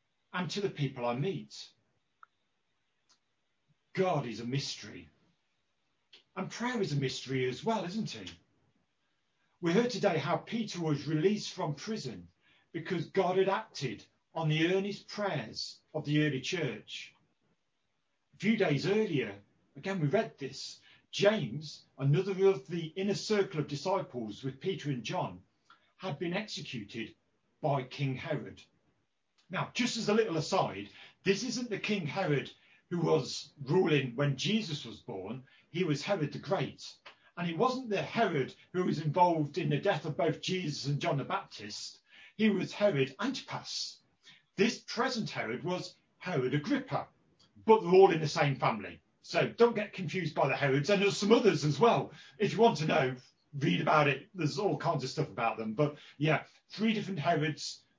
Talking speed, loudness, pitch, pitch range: 160 wpm, -32 LUFS, 165 Hz, 140-195 Hz